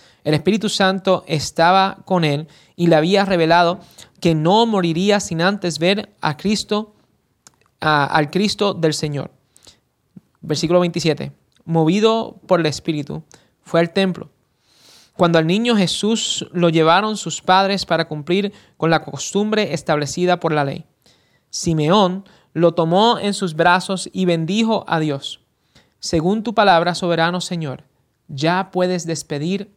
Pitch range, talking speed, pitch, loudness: 160-195 Hz, 135 wpm, 175 Hz, -18 LUFS